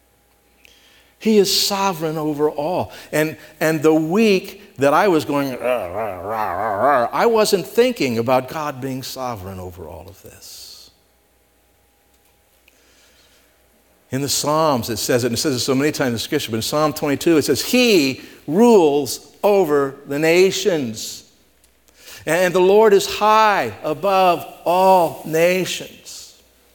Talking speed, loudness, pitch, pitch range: 140 wpm, -18 LUFS, 155 Hz, 125-185 Hz